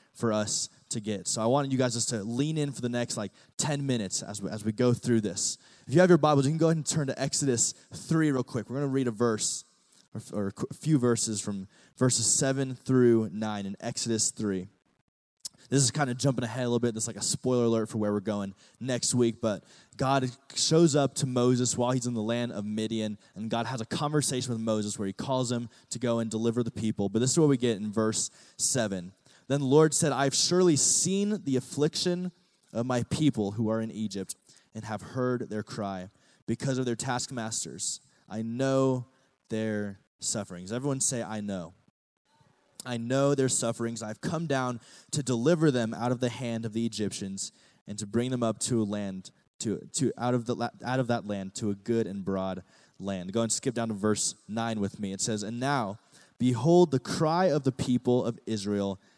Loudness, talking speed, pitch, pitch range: -28 LUFS, 220 wpm, 120 Hz, 110-135 Hz